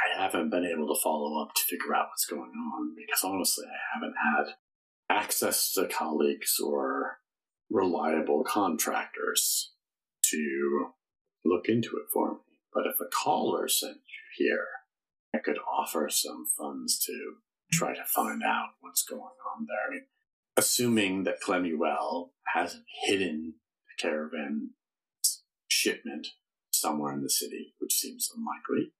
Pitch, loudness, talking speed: 265 Hz, -29 LUFS, 145 wpm